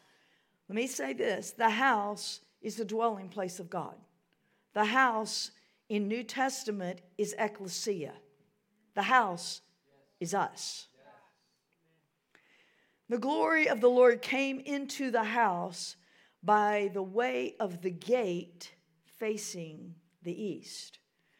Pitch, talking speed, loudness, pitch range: 210 Hz, 115 wpm, -31 LUFS, 180-230 Hz